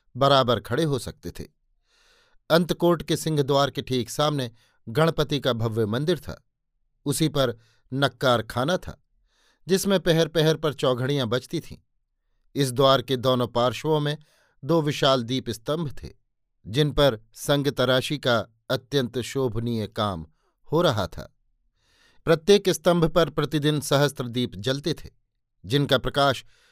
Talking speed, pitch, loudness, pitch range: 135 wpm, 135 Hz, -24 LUFS, 120-150 Hz